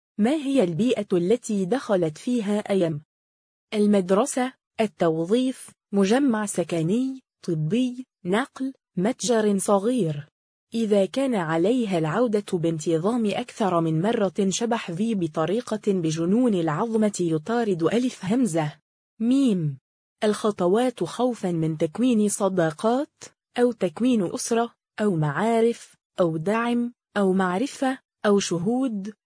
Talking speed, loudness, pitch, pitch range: 100 wpm, -24 LUFS, 210 Hz, 175-235 Hz